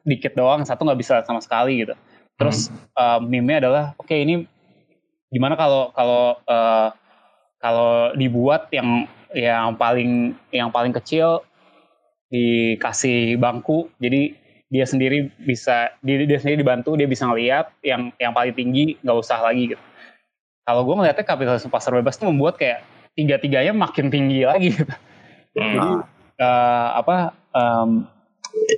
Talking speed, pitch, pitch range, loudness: 140 wpm, 125 Hz, 120-145 Hz, -20 LUFS